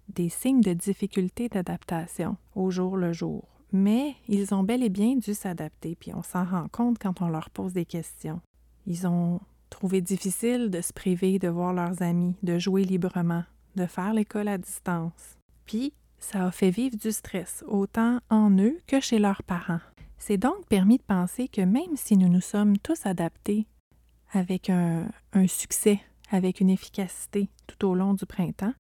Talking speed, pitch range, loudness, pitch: 180 wpm, 180-215 Hz, -27 LUFS, 190 Hz